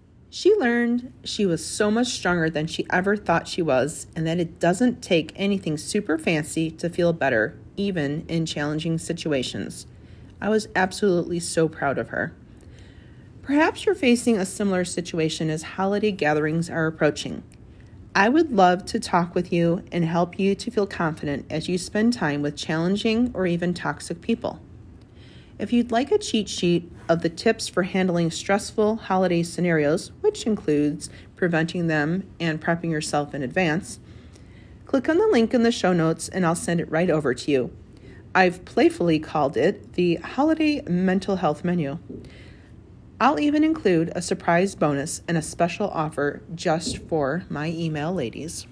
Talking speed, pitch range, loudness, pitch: 165 wpm, 160-200 Hz, -23 LUFS, 175 Hz